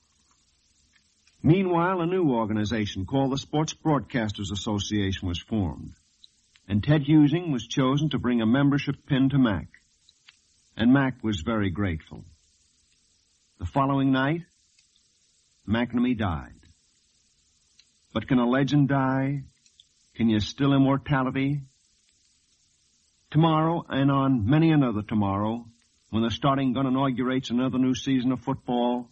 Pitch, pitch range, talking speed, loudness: 120 Hz, 95-135 Hz, 120 wpm, -25 LUFS